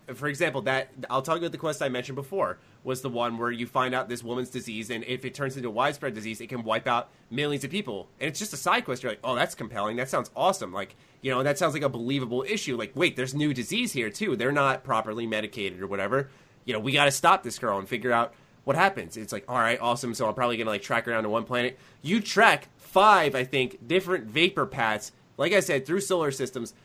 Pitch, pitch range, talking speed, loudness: 130 Hz, 120-150 Hz, 255 wpm, -27 LUFS